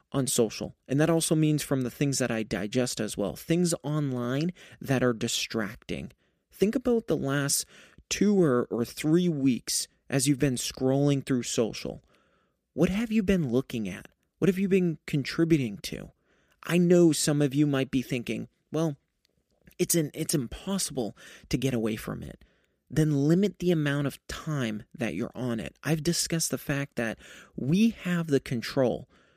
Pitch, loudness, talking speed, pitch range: 145 Hz, -28 LUFS, 170 wpm, 125-170 Hz